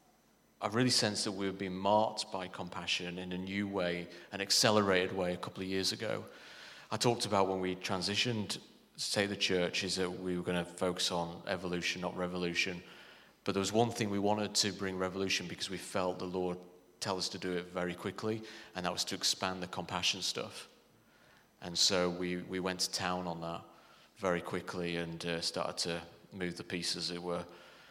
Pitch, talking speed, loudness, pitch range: 90 Hz, 200 wpm, -34 LUFS, 90-100 Hz